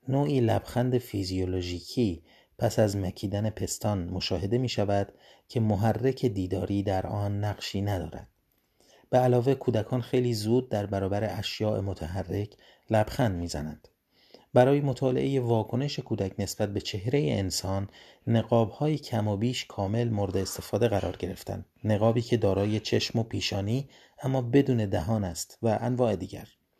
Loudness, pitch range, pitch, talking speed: -28 LUFS, 100-120 Hz, 105 Hz, 130 wpm